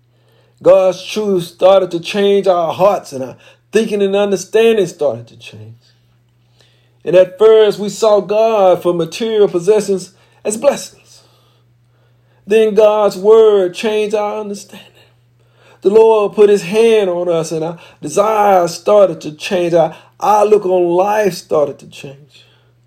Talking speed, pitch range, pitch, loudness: 135 wpm, 130-210 Hz, 185 Hz, -13 LUFS